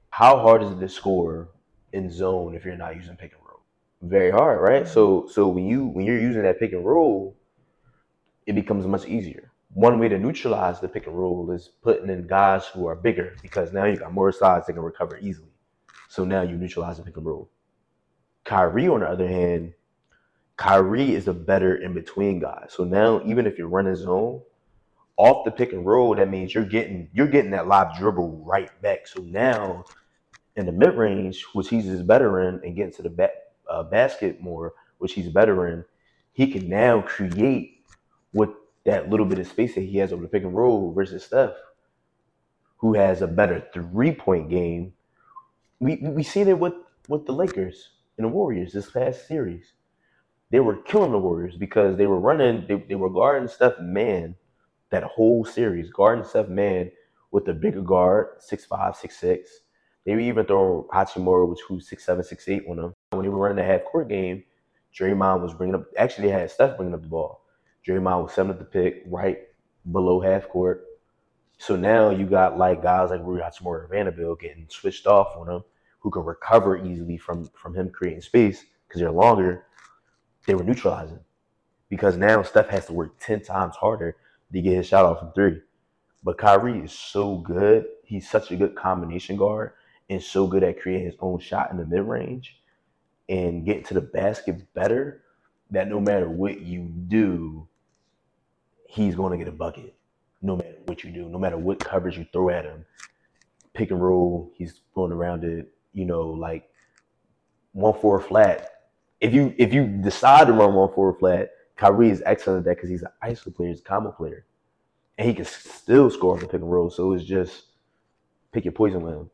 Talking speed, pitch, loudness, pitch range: 195 wpm, 95 Hz, -22 LUFS, 90-105 Hz